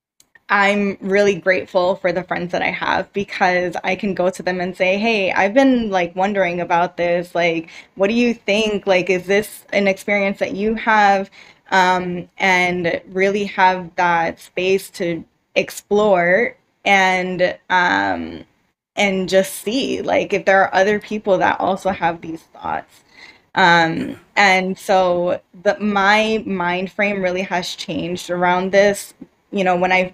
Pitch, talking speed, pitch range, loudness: 190 Hz, 155 wpm, 180-200 Hz, -17 LUFS